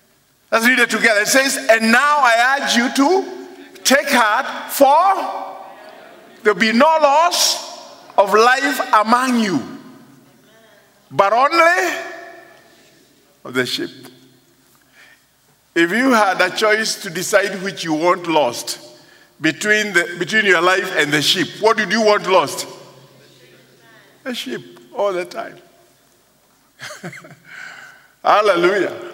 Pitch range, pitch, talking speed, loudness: 210-325 Hz, 250 Hz, 120 wpm, -15 LUFS